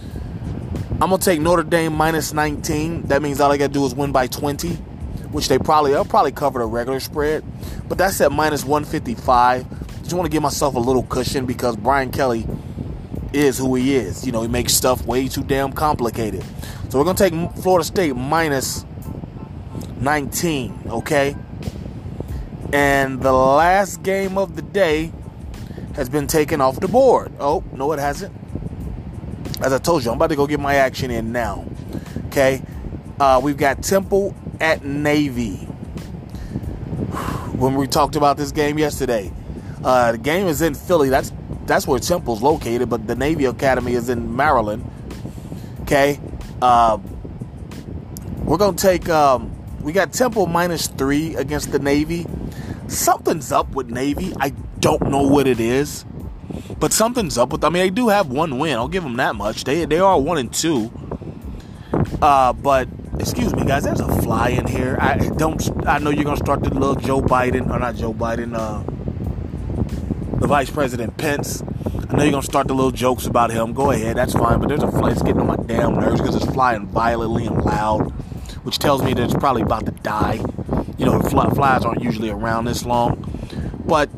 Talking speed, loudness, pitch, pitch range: 180 wpm, -19 LUFS, 140 Hz, 120-150 Hz